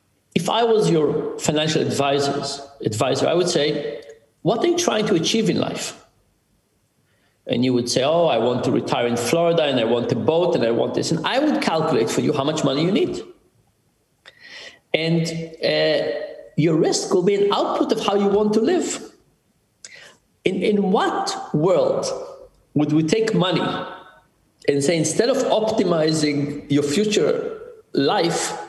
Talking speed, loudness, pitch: 165 wpm, -20 LUFS, 185 Hz